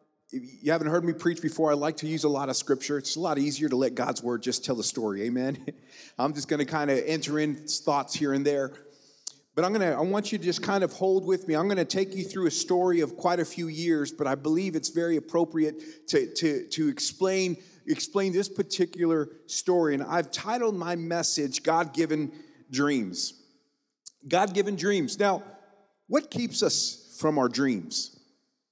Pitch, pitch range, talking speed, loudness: 165 Hz, 150-190 Hz, 205 wpm, -27 LUFS